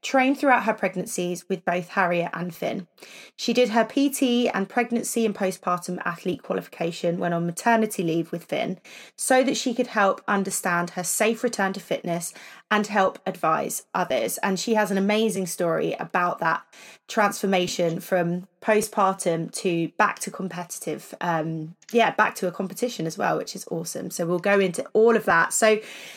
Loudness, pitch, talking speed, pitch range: -24 LUFS, 195 Hz, 170 wpm, 175-220 Hz